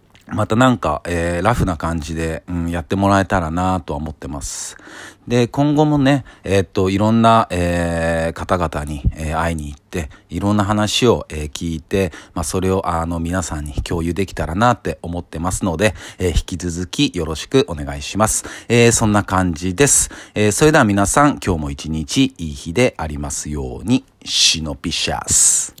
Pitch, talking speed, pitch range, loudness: 90 Hz, 355 characters per minute, 80-105 Hz, -18 LUFS